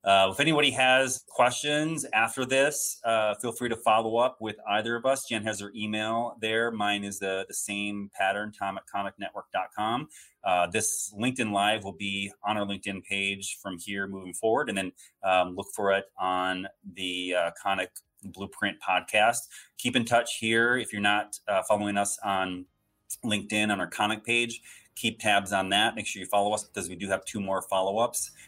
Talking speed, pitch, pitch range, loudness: 190 wpm, 105 Hz, 100-115 Hz, -28 LUFS